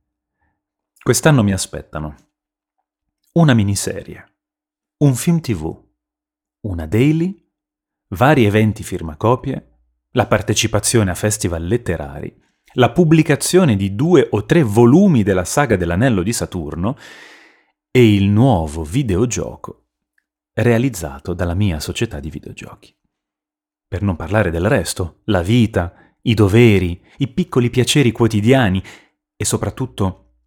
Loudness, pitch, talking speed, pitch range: -16 LUFS, 105 Hz, 110 wpm, 90-130 Hz